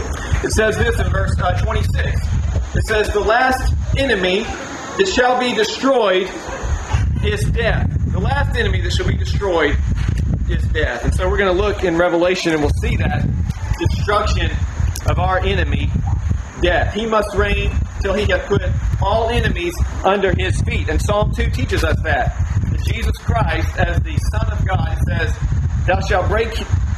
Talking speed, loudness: 160 wpm, -18 LUFS